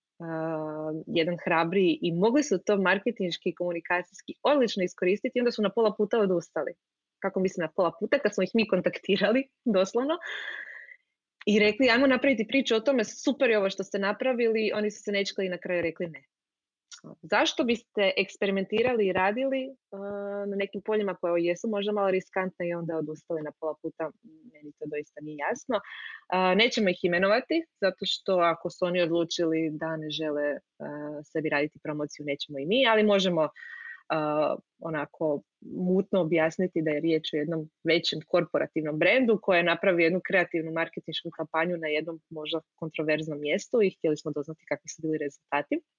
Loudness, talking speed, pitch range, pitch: -27 LUFS, 170 wpm, 160-210 Hz, 180 Hz